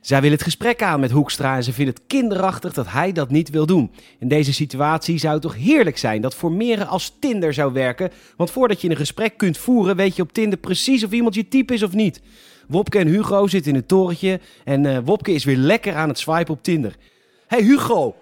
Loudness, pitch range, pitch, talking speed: -19 LUFS, 145-210 Hz, 170 Hz, 235 wpm